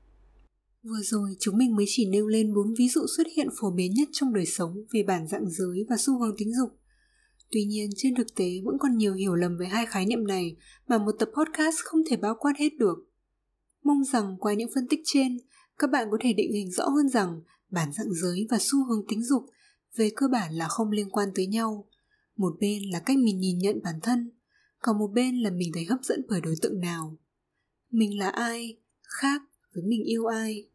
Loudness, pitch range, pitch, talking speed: -27 LUFS, 200-255 Hz, 220 Hz, 225 wpm